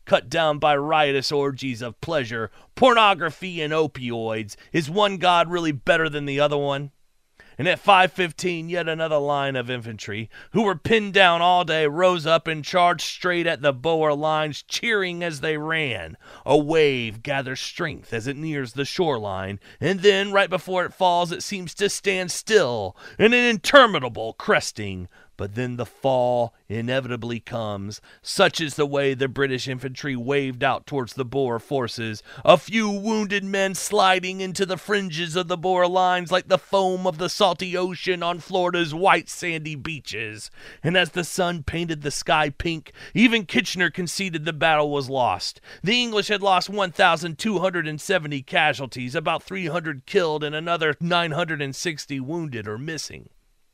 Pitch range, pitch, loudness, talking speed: 135-185 Hz, 160 Hz, -22 LUFS, 160 wpm